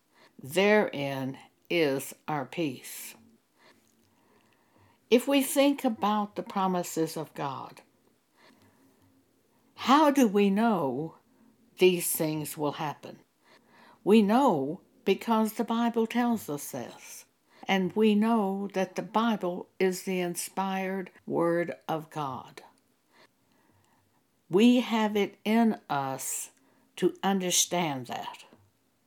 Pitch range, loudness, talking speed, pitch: 160-225 Hz, -28 LUFS, 100 wpm, 190 Hz